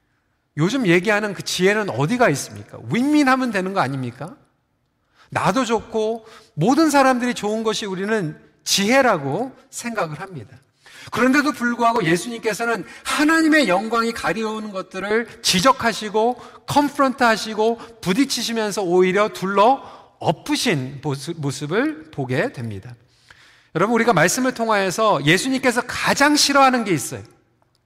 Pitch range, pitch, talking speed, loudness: 165-245 Hz, 220 Hz, 315 characters per minute, -19 LUFS